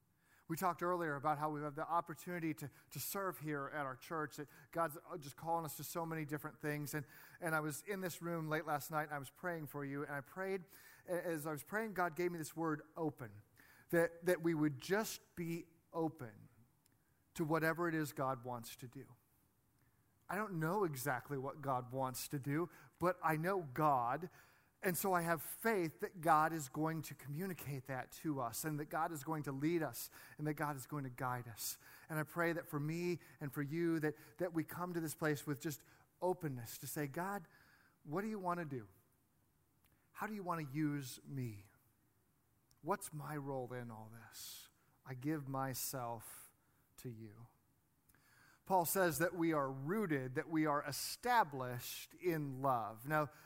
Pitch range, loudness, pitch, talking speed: 135-170 Hz, -41 LUFS, 150 Hz, 195 wpm